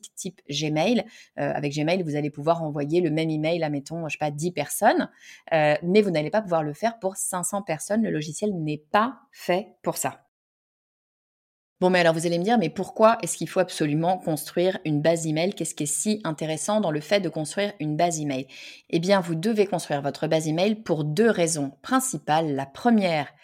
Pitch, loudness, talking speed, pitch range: 165 Hz, -25 LUFS, 210 wpm, 155-195 Hz